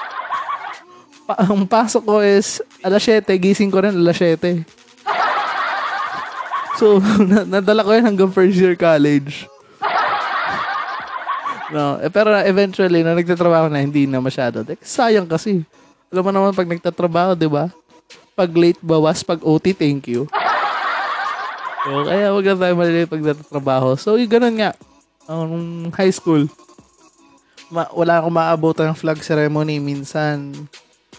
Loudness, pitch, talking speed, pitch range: -17 LUFS, 175 Hz, 135 wpm, 155-200 Hz